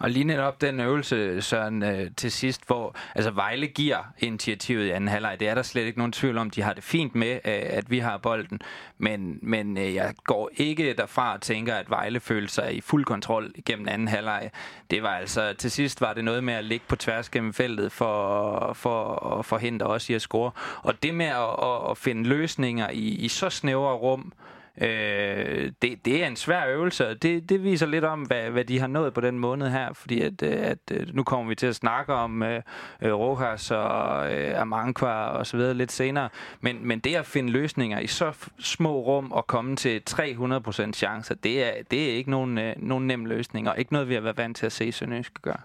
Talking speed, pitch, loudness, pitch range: 215 wpm, 120 Hz, -27 LUFS, 110-135 Hz